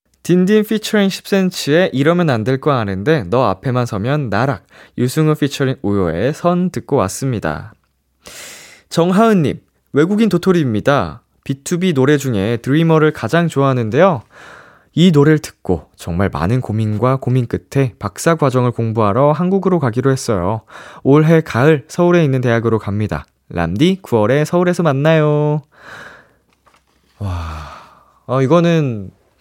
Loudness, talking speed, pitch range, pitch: -15 LUFS, 290 characters per minute, 105-160 Hz, 135 Hz